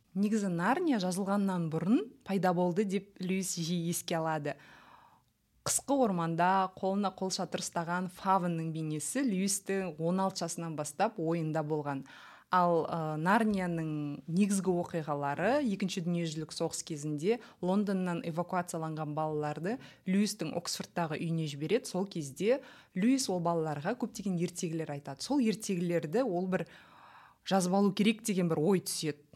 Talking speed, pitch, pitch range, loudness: 120 wpm, 180 Hz, 165-200 Hz, -32 LUFS